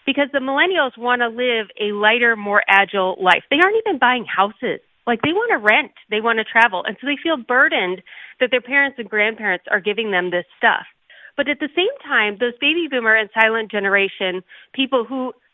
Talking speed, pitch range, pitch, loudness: 205 wpm, 205-275 Hz, 235 Hz, -18 LUFS